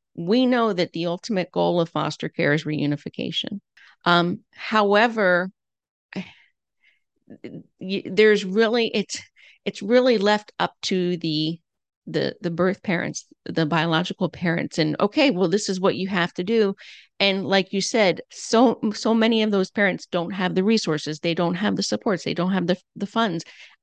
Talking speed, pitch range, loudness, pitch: 160 wpm, 170-215 Hz, -22 LUFS, 190 Hz